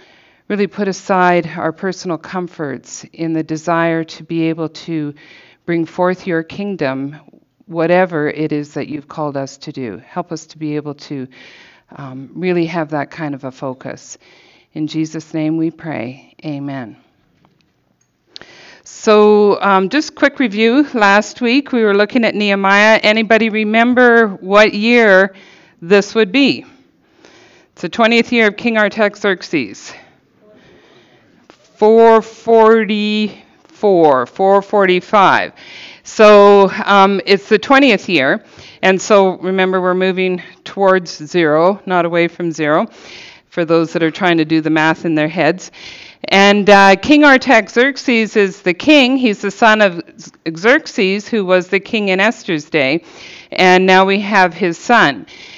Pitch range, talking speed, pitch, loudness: 165-215 Hz, 140 wpm, 190 Hz, -13 LUFS